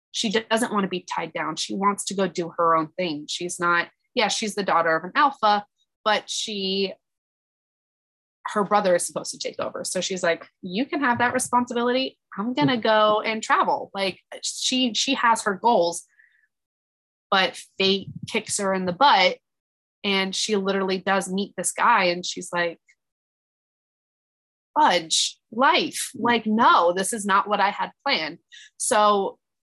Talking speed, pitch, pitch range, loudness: 165 wpm, 200 Hz, 175-230 Hz, -23 LUFS